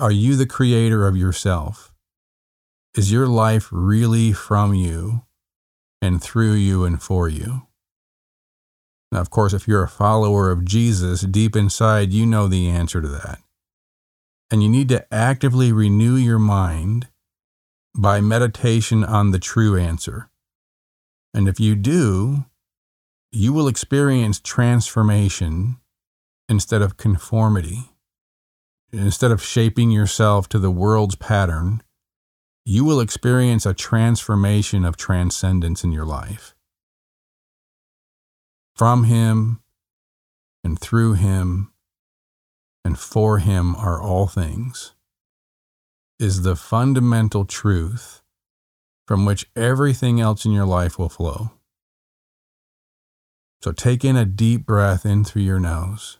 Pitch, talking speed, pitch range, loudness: 100 Hz, 120 wpm, 90-115 Hz, -19 LUFS